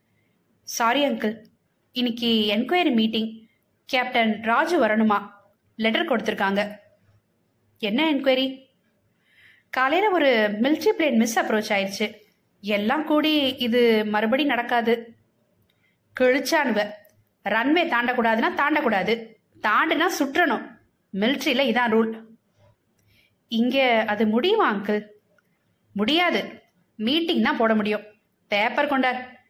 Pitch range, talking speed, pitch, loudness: 215-275 Hz, 90 wpm, 235 Hz, -22 LUFS